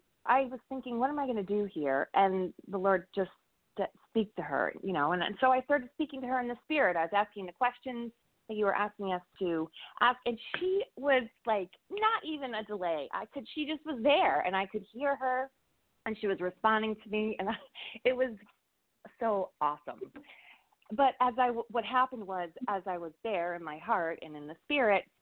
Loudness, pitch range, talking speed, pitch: -32 LUFS, 190-260 Hz, 215 wpm, 220 Hz